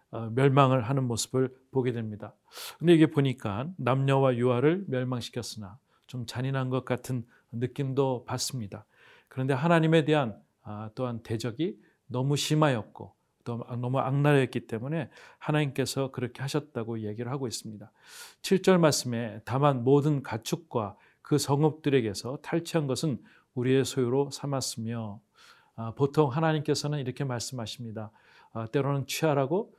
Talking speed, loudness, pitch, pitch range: 310 characters per minute, -28 LUFS, 130 Hz, 120-145 Hz